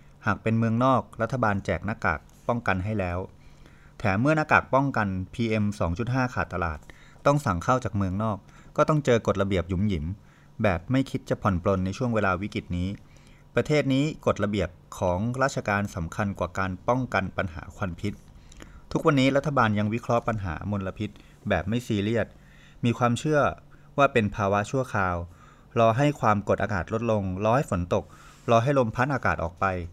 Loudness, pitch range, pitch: -26 LUFS, 95-125 Hz, 105 Hz